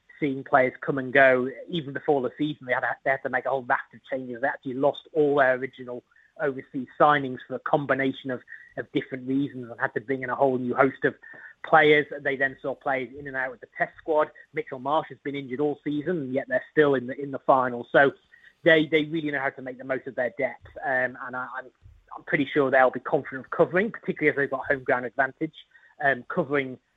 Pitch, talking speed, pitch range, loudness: 135 Hz, 240 wpm, 130-150 Hz, -25 LUFS